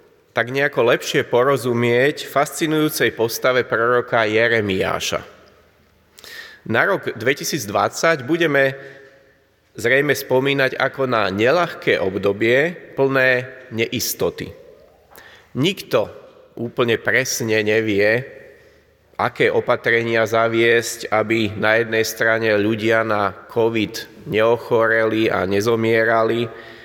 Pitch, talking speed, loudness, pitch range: 115 Hz, 85 wpm, -18 LUFS, 110-135 Hz